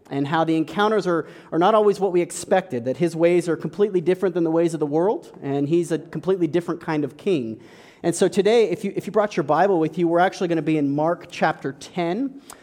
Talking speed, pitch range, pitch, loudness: 245 wpm, 160-190 Hz, 170 Hz, -22 LUFS